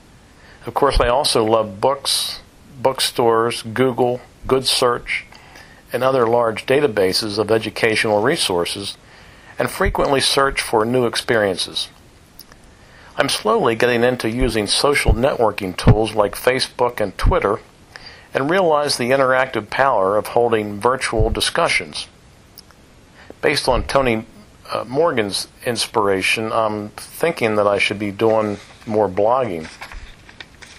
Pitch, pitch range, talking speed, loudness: 115 Hz, 105-125 Hz, 115 wpm, -18 LUFS